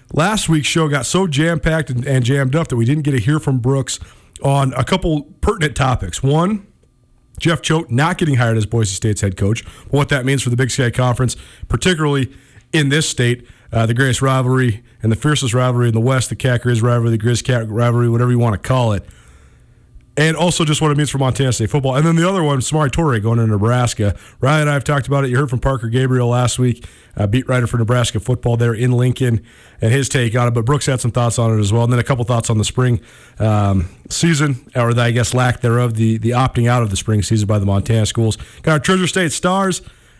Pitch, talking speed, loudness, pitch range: 125 Hz, 240 wpm, -16 LUFS, 115-145 Hz